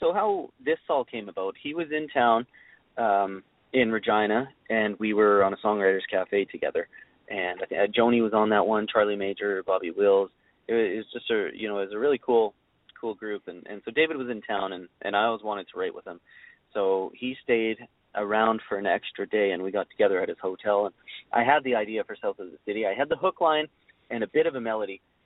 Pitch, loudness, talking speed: 110 Hz, -26 LUFS, 230 wpm